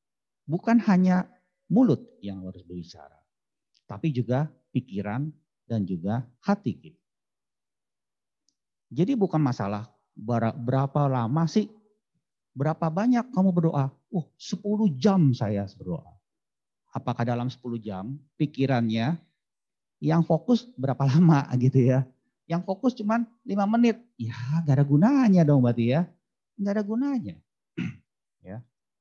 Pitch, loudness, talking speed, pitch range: 145 Hz, -25 LUFS, 110 wpm, 125-190 Hz